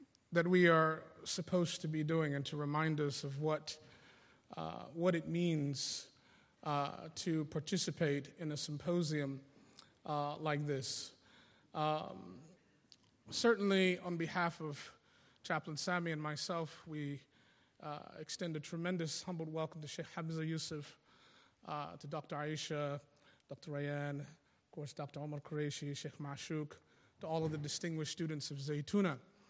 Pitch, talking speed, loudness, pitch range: 155 Hz, 135 wpm, -39 LUFS, 145-170 Hz